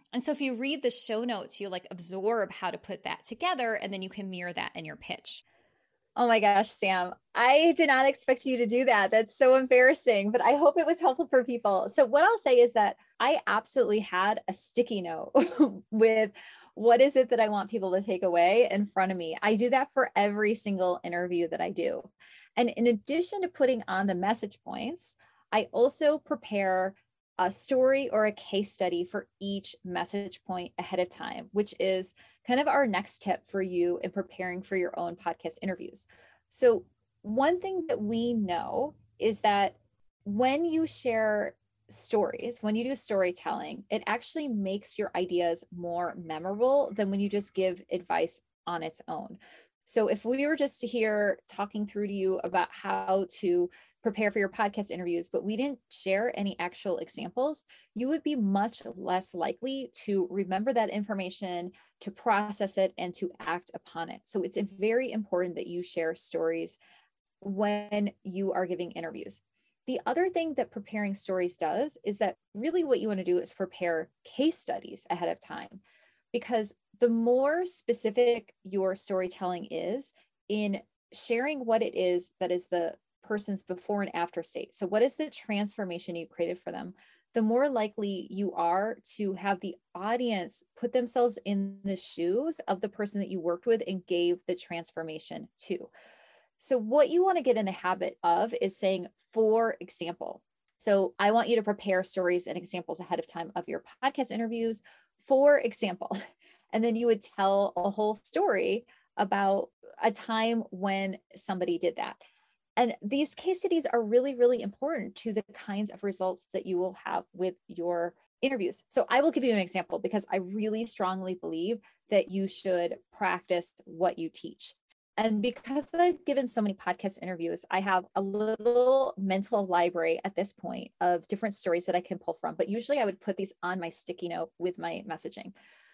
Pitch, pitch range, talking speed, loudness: 205 Hz, 185-240 Hz, 185 wpm, -29 LUFS